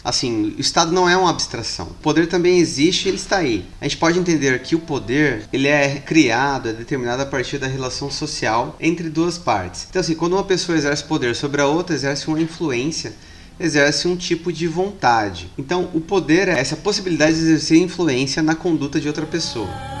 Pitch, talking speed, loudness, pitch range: 155 Hz, 200 wpm, -19 LUFS, 140-170 Hz